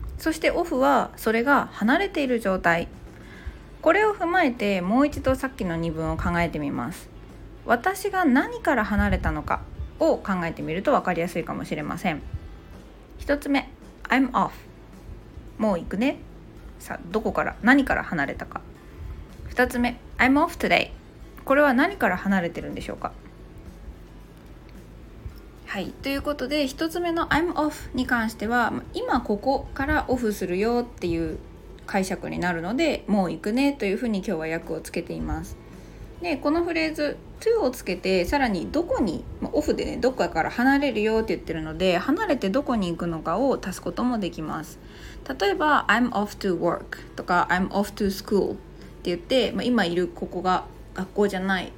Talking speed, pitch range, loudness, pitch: 345 characters per minute, 180-280 Hz, -24 LUFS, 225 Hz